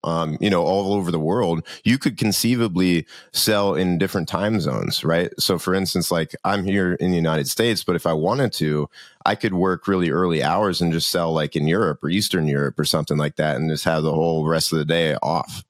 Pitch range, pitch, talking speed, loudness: 80-95 Hz, 85 Hz, 230 wpm, -21 LUFS